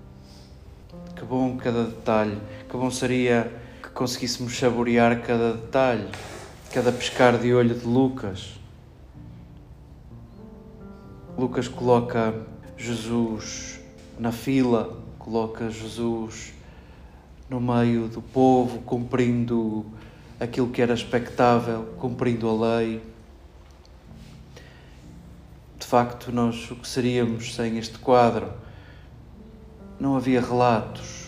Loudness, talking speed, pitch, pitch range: -24 LUFS, 90 wpm, 115 Hz, 110-125 Hz